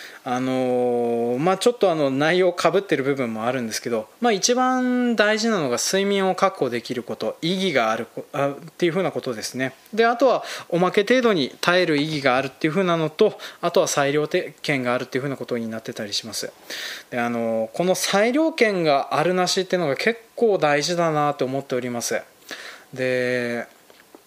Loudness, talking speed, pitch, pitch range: -22 LUFS, 370 characters per minute, 150 Hz, 125-190 Hz